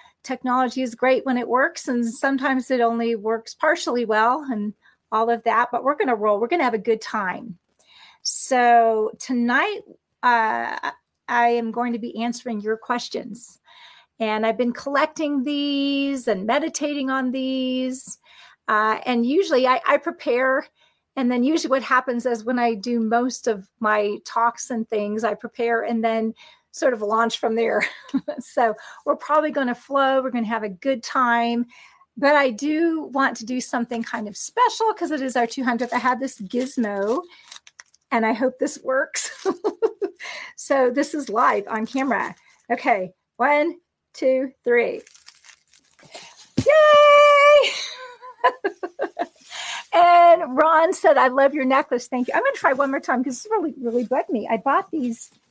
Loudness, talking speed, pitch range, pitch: -21 LUFS, 165 wpm, 235-290 Hz, 255 Hz